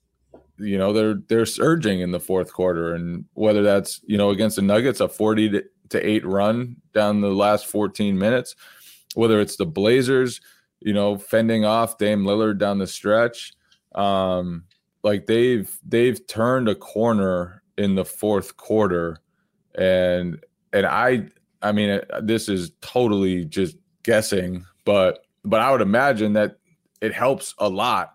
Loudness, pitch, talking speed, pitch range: -21 LUFS, 105 Hz, 155 wpm, 95-110 Hz